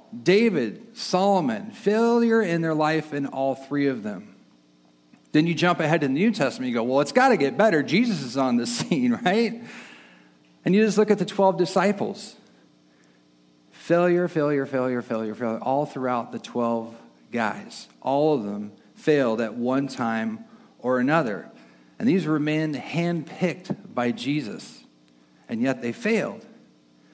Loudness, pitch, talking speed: -24 LUFS, 145 Hz, 155 wpm